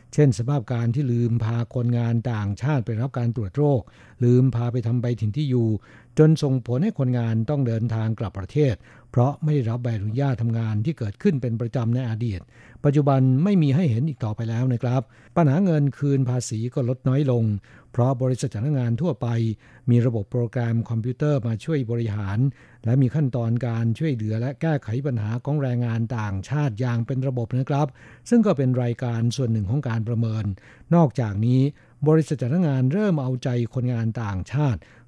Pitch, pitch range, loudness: 125 Hz, 115-140 Hz, -23 LUFS